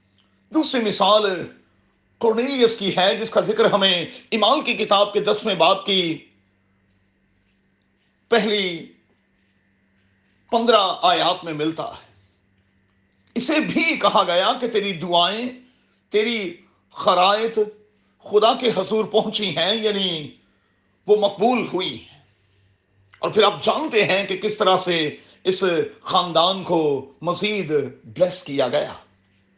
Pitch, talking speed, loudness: 185 Hz, 115 wpm, -20 LUFS